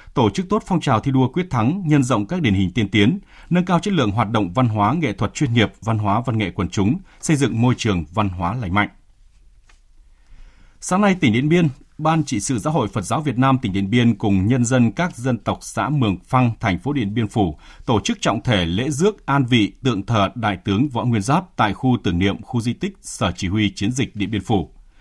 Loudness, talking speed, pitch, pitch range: -20 LUFS, 245 wpm, 120 Hz, 105-145 Hz